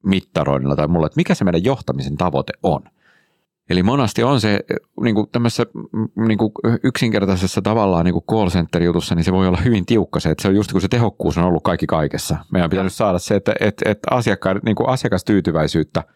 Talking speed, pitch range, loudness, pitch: 190 wpm, 85-110 Hz, -18 LUFS, 95 Hz